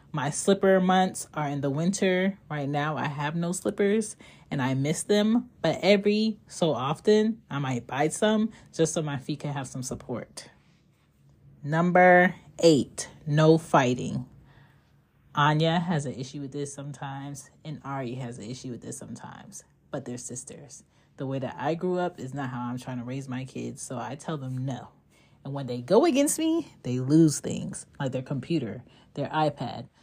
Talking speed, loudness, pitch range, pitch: 180 wpm, -27 LUFS, 130-170 Hz, 145 Hz